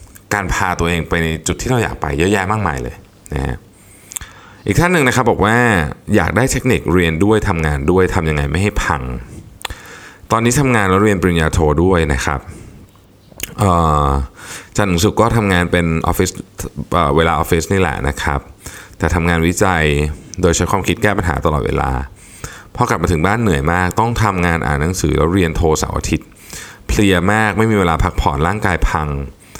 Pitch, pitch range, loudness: 90 Hz, 80-105 Hz, -15 LUFS